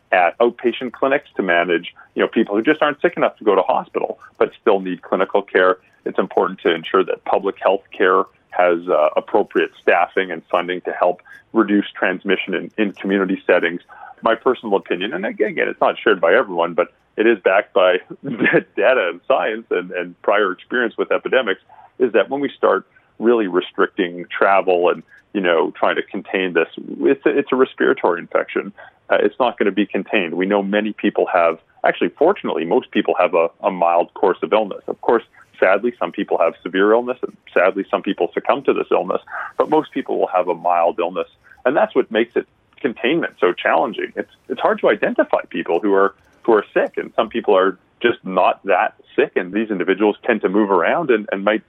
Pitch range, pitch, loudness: 90-135 Hz, 105 Hz, -18 LUFS